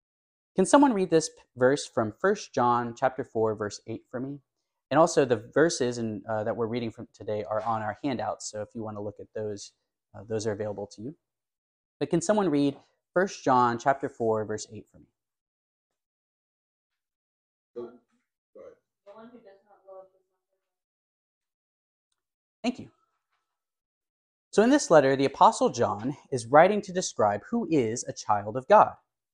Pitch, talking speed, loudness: 120 Hz, 150 wpm, -26 LUFS